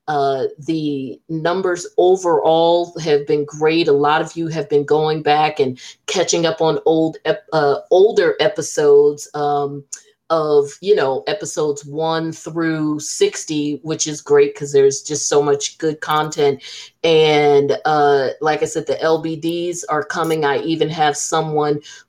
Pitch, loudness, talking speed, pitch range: 155 Hz, -17 LUFS, 145 wpm, 145-165 Hz